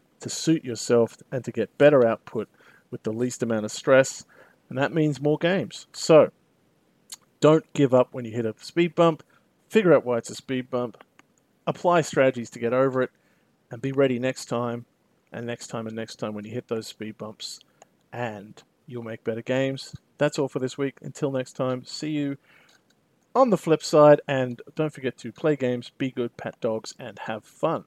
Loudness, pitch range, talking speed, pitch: -24 LUFS, 120-145 Hz, 195 wpm, 130 Hz